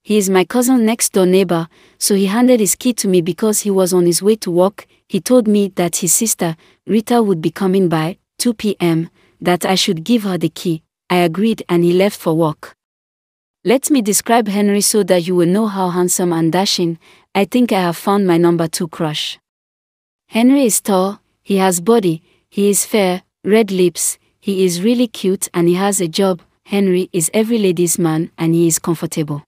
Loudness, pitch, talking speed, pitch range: -15 LUFS, 190 Hz, 205 wpm, 175-210 Hz